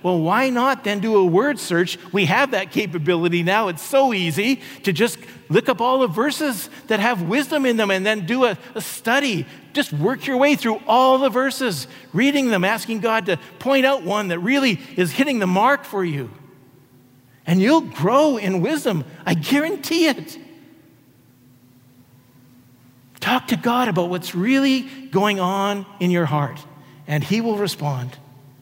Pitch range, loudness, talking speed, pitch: 155-255 Hz, -20 LUFS, 170 wpm, 200 Hz